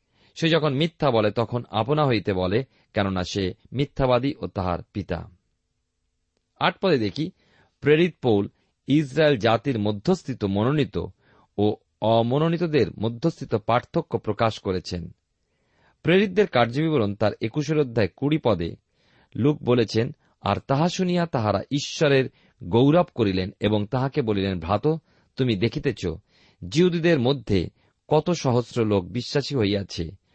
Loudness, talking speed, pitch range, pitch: -24 LUFS, 115 wpm, 105-150 Hz, 120 Hz